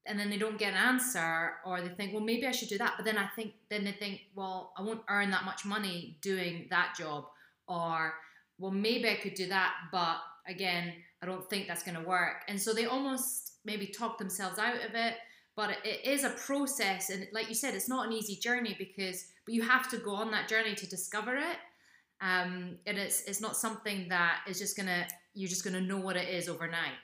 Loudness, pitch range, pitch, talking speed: -34 LUFS, 180-220 Hz, 200 Hz, 235 wpm